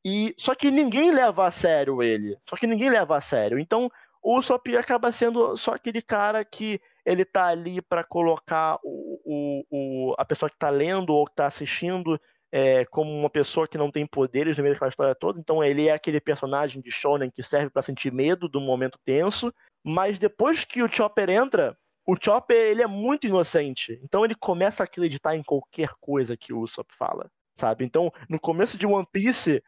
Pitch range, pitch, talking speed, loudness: 145-215 Hz, 165 Hz, 200 wpm, -24 LUFS